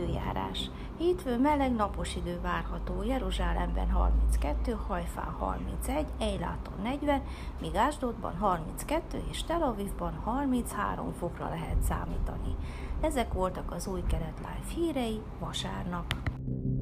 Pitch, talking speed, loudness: 175 Hz, 105 wpm, -33 LUFS